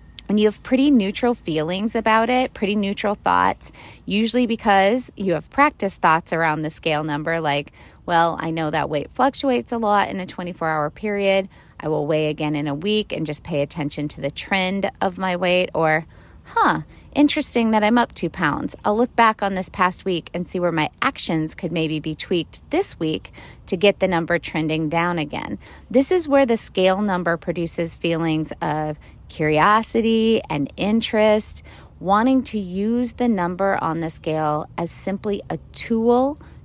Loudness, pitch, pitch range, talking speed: -21 LUFS, 185 Hz, 160-220 Hz, 175 wpm